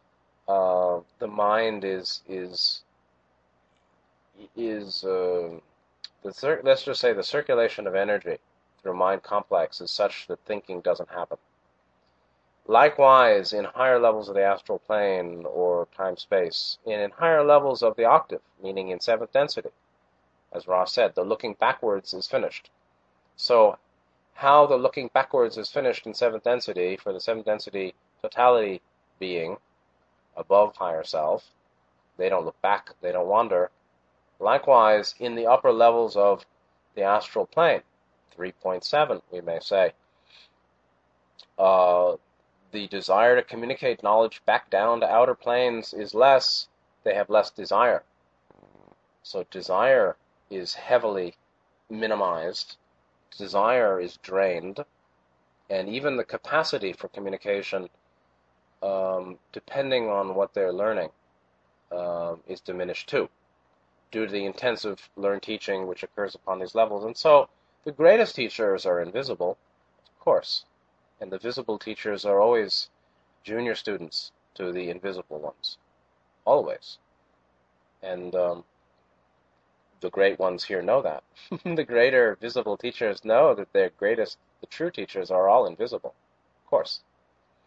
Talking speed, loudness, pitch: 130 wpm, -24 LUFS, 90 Hz